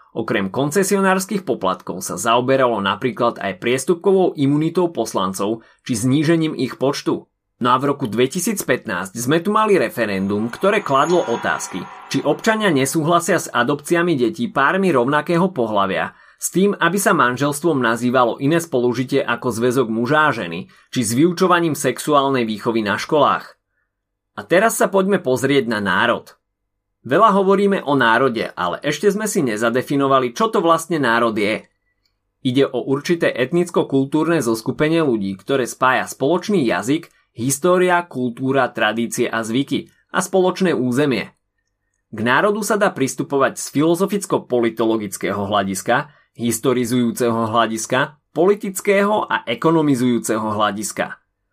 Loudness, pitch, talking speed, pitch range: -18 LUFS, 135 Hz, 125 wpm, 115-175 Hz